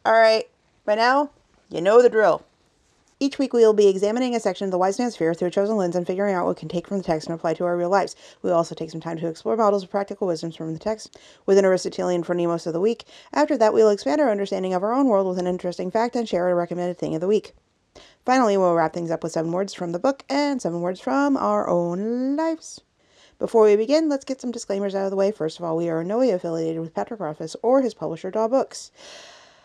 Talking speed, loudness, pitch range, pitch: 270 wpm, -22 LUFS, 175-240 Hz, 200 Hz